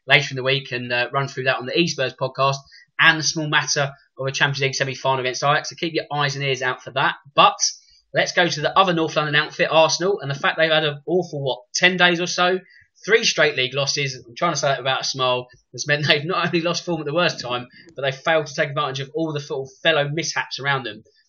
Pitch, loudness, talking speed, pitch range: 150 Hz, -20 LUFS, 255 wpm, 135-170 Hz